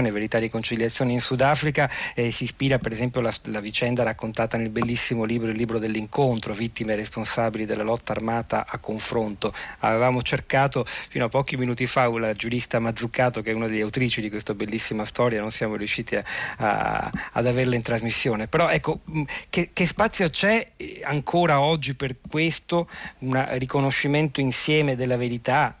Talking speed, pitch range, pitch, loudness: 165 wpm, 110-135 Hz, 120 Hz, -24 LUFS